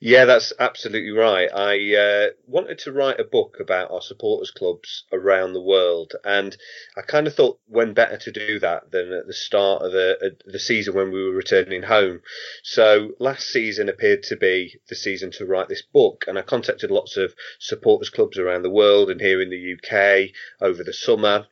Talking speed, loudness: 200 wpm, -20 LUFS